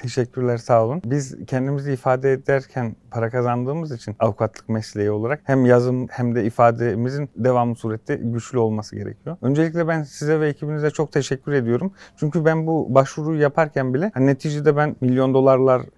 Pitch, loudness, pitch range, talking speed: 130 Hz, -21 LUFS, 120-150 Hz, 160 wpm